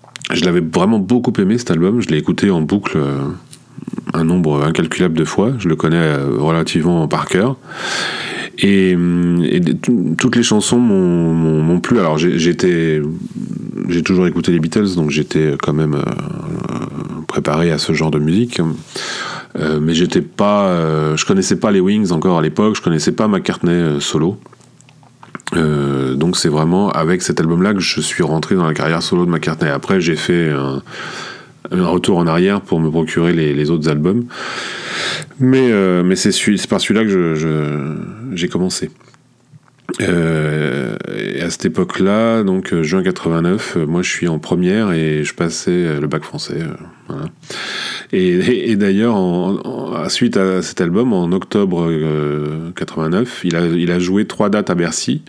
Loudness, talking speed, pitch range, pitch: -16 LUFS, 165 wpm, 80-100 Hz, 85 Hz